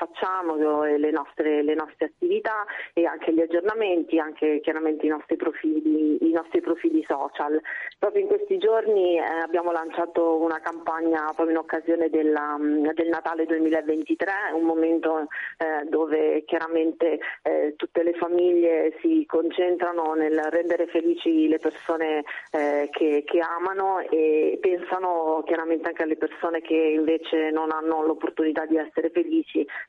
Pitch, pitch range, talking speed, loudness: 165 Hz, 155-170 Hz, 130 wpm, -24 LUFS